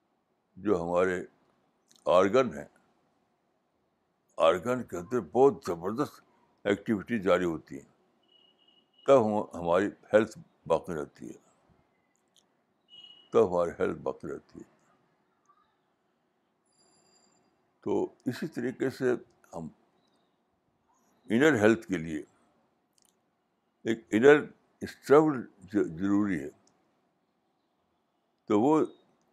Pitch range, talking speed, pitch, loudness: 100-140 Hz, 85 wpm, 120 Hz, -28 LUFS